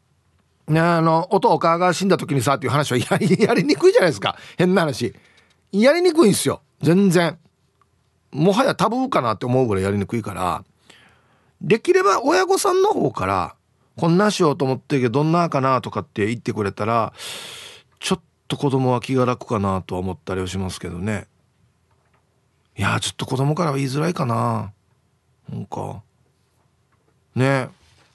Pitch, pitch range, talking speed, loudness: 135 Hz, 110-175 Hz, 330 characters per minute, -20 LUFS